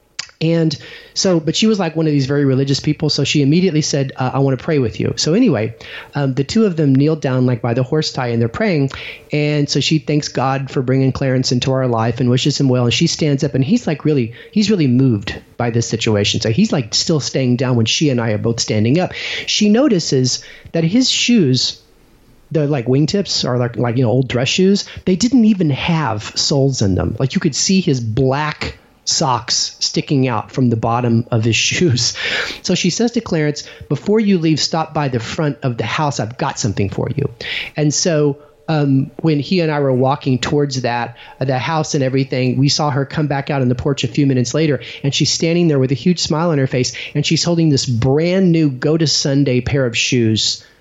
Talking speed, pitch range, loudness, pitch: 225 wpm, 125-160 Hz, -16 LUFS, 140 Hz